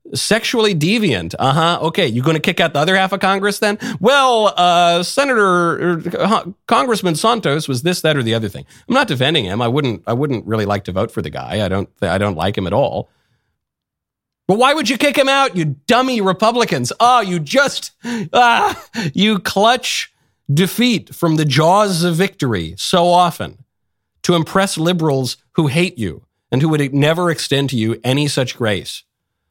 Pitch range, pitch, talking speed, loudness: 130-205 Hz, 170 Hz, 190 wpm, -15 LUFS